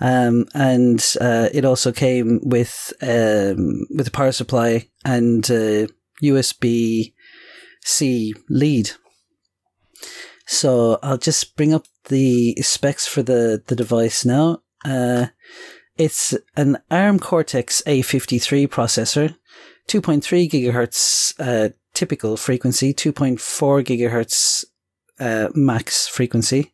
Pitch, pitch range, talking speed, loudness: 125 Hz, 115-140 Hz, 105 wpm, -18 LUFS